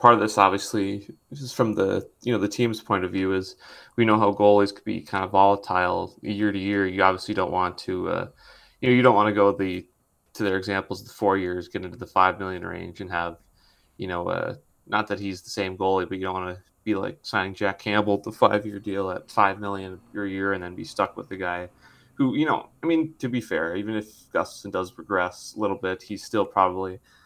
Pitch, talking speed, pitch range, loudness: 100 Hz, 240 wpm, 95-105 Hz, -25 LUFS